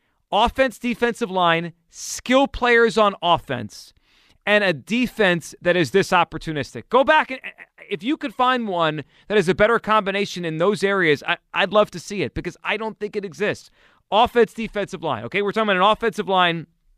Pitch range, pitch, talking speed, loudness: 170-225 Hz, 200 Hz, 185 wpm, -20 LUFS